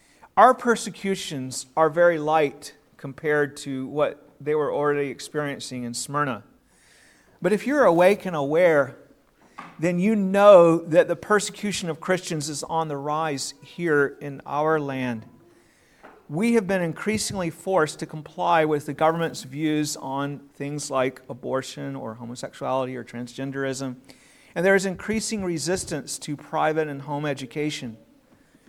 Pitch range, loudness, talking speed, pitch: 140-175 Hz, -23 LUFS, 135 wpm, 150 Hz